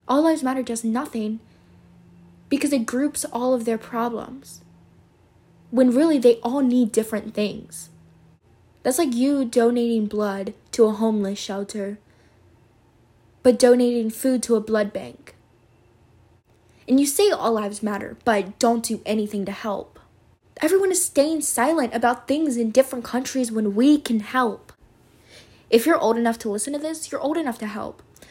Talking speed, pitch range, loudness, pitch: 155 wpm, 195-255 Hz, -22 LUFS, 225 Hz